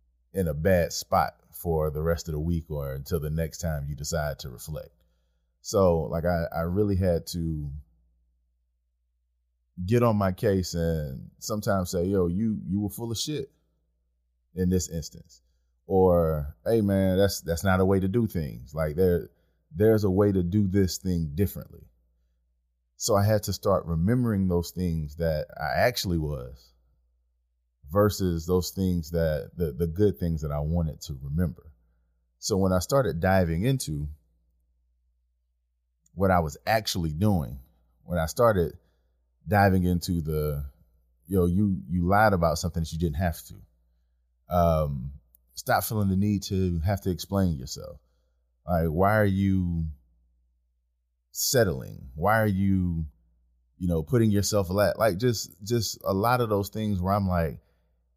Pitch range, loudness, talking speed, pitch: 65-95 Hz, -26 LUFS, 160 wpm, 85 Hz